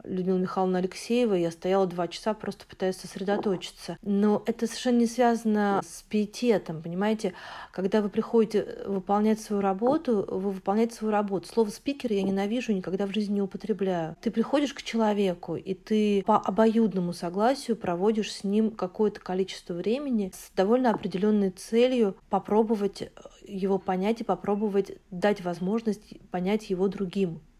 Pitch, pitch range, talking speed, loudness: 205 Hz, 190-220 Hz, 145 wpm, -27 LUFS